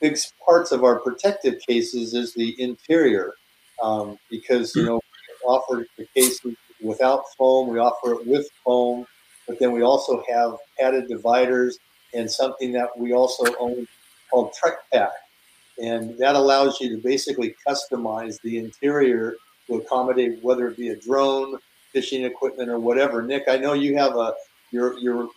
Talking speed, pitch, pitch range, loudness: 160 wpm, 125 Hz, 120-135 Hz, -22 LUFS